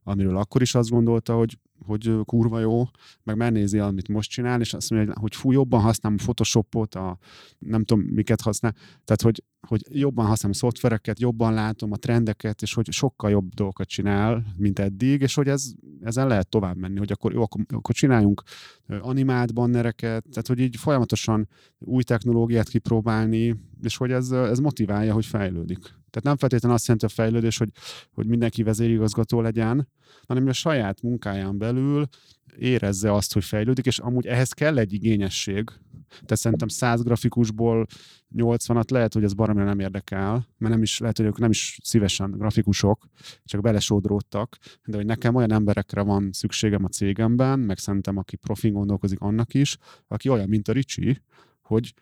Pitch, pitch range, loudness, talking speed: 115 Hz, 105-120 Hz, -24 LUFS, 170 wpm